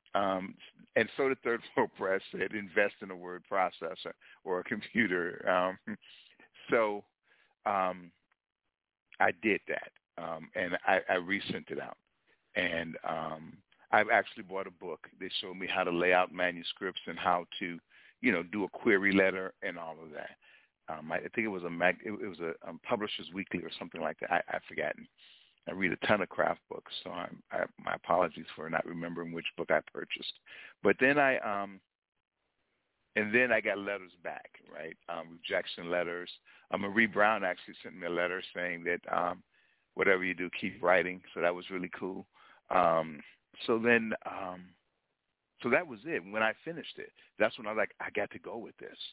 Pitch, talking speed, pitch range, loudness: 90 Hz, 190 wpm, 85-100 Hz, -32 LUFS